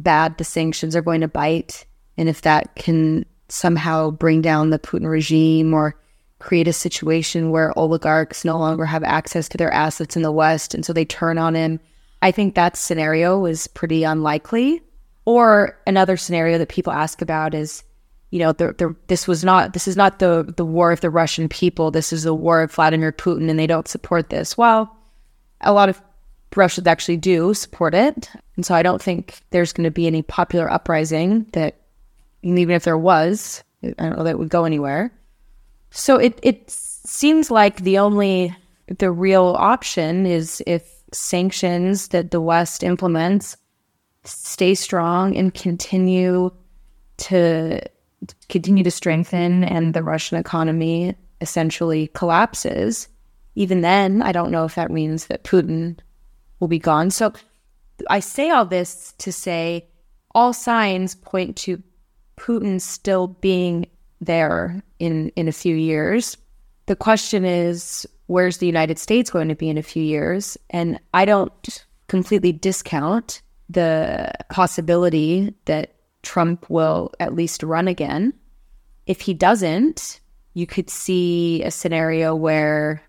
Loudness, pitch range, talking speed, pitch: -19 LUFS, 160-190 Hz, 155 wpm, 175 Hz